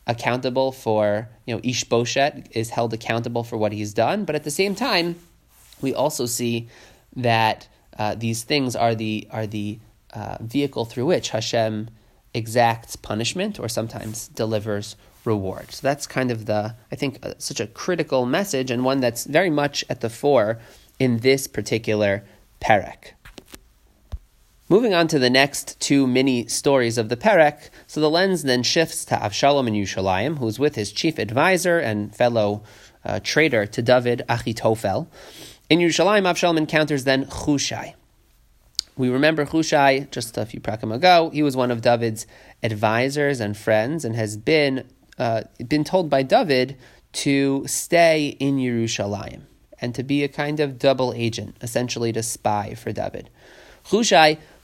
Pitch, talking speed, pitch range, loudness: 120 Hz, 160 wpm, 110-145 Hz, -21 LUFS